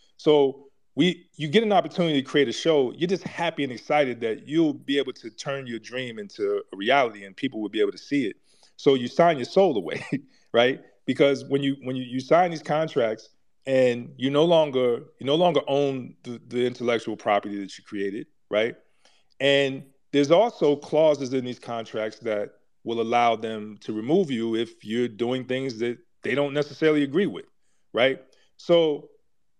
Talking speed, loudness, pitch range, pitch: 185 wpm, -24 LUFS, 120-155 Hz, 135 Hz